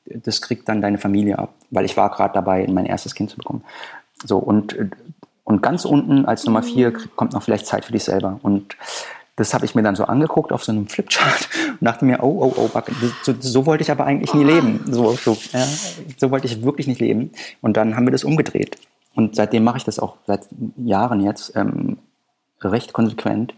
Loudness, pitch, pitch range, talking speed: -19 LUFS, 115 Hz, 105-130 Hz, 215 wpm